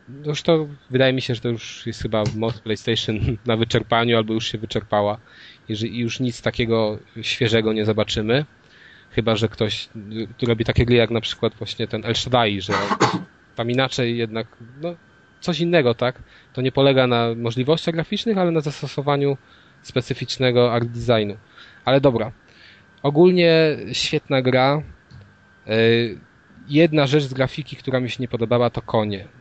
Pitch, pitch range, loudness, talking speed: 120 Hz, 110-135 Hz, -21 LUFS, 155 wpm